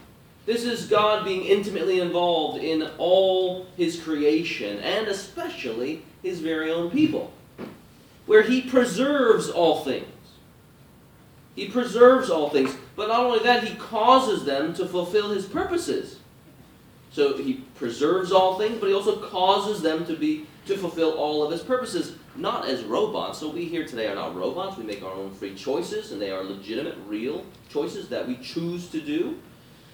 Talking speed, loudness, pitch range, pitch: 160 wpm, -24 LUFS, 160-245 Hz, 190 Hz